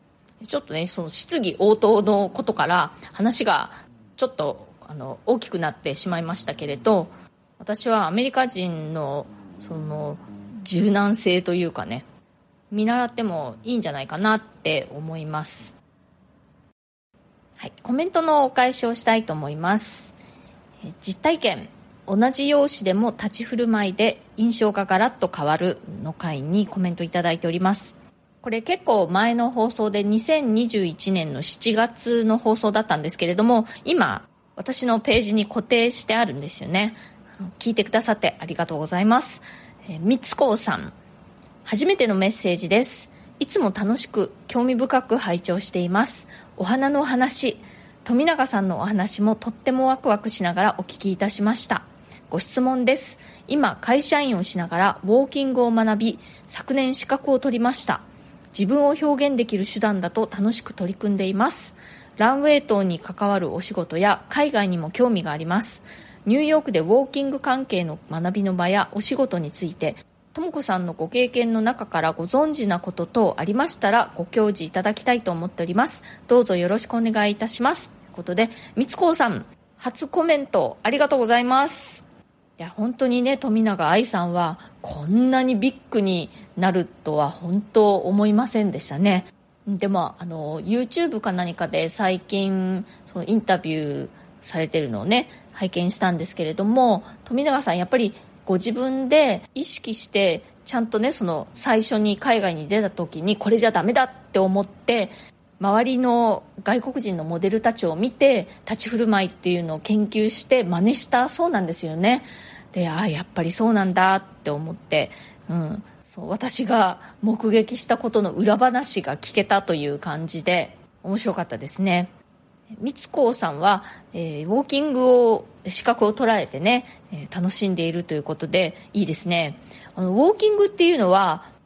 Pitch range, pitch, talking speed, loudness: 180-240 Hz, 210 Hz, 335 characters per minute, -22 LUFS